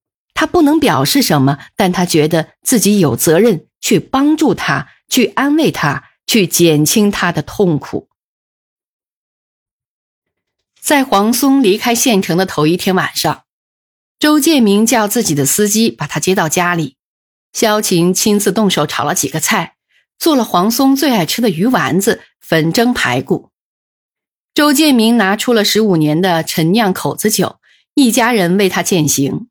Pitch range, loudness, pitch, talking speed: 160-235 Hz, -13 LUFS, 195 Hz, 220 characters per minute